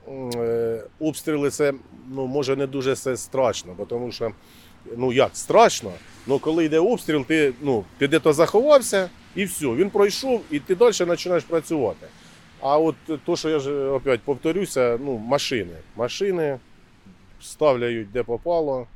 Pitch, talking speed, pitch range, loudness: 140 Hz, 140 wpm, 120-160 Hz, -22 LUFS